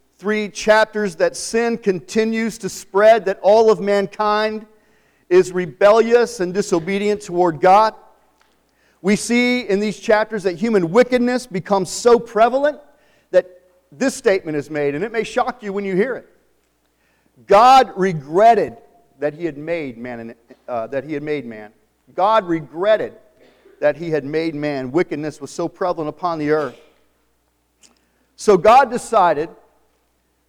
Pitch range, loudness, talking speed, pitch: 160-220 Hz, -17 LUFS, 140 wpm, 195 Hz